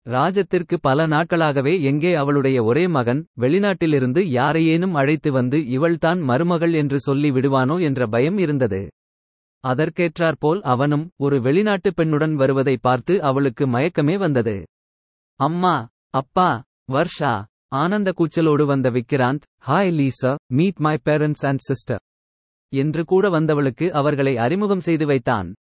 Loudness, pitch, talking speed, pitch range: -19 LUFS, 145 Hz, 115 wpm, 130-165 Hz